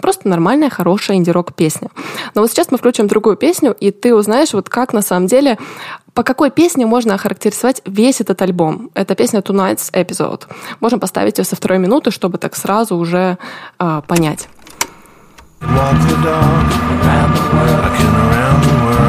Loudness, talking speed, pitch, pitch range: -13 LUFS, 140 wpm, 200 Hz, 180-245 Hz